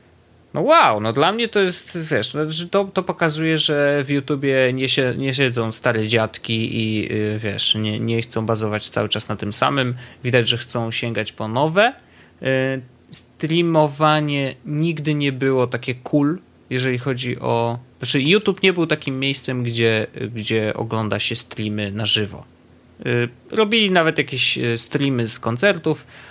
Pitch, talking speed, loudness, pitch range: 130 Hz, 145 wpm, -20 LUFS, 115-150 Hz